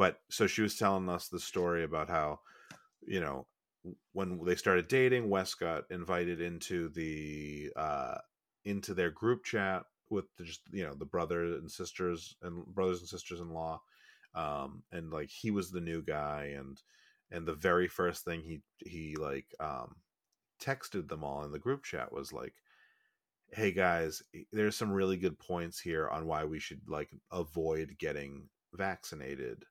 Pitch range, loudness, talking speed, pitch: 80-95 Hz, -36 LUFS, 170 wpm, 85 Hz